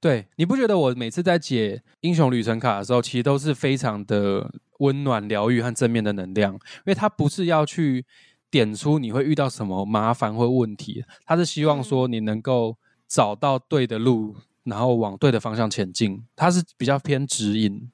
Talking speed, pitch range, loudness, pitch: 280 characters per minute, 110-145 Hz, -23 LUFS, 125 Hz